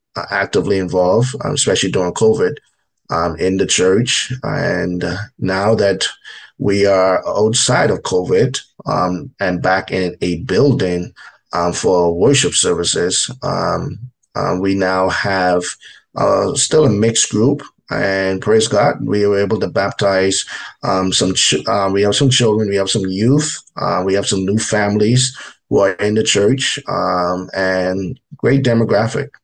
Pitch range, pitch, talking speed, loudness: 95-120 Hz, 100 Hz, 145 wpm, -15 LUFS